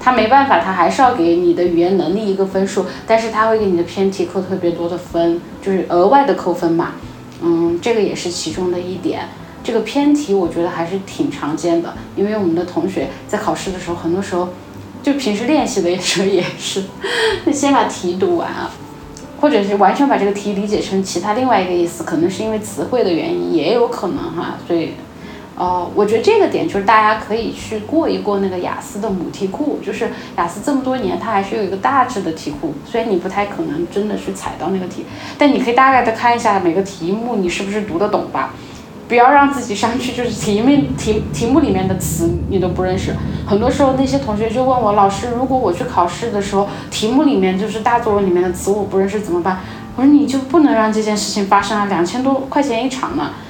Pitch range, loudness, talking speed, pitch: 180-245 Hz, -16 LUFS, 340 characters per minute, 205 Hz